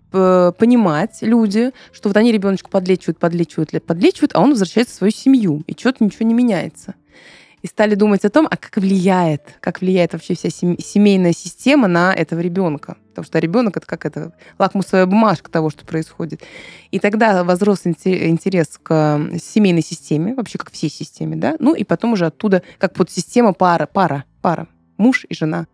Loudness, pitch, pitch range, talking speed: -16 LUFS, 185 Hz, 165-215 Hz, 175 wpm